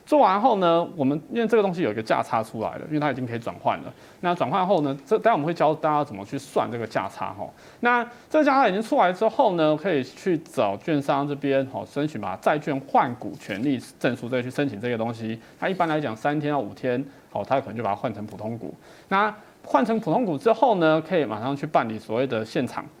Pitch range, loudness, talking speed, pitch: 130-200 Hz, -24 LUFS, 355 characters per minute, 150 Hz